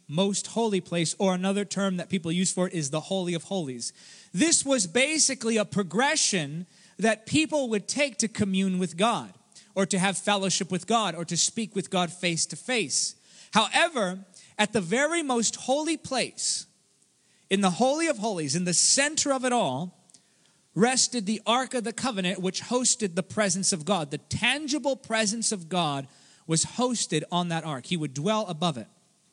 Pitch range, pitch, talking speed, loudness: 175-230 Hz, 195 Hz, 180 wpm, -26 LUFS